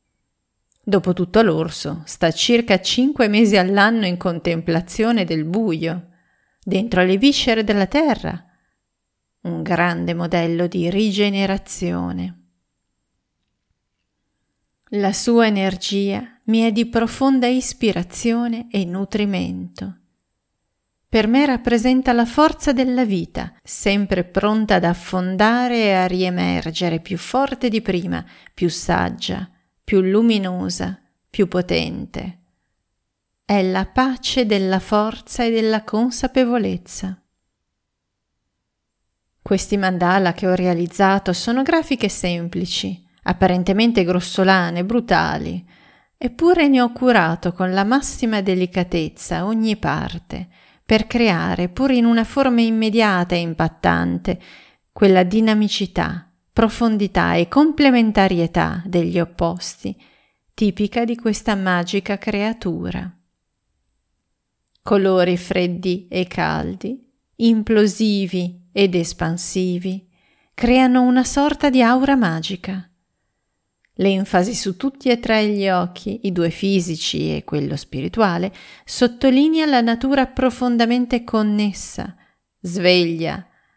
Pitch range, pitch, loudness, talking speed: 175-230 Hz, 195 Hz, -18 LUFS, 100 wpm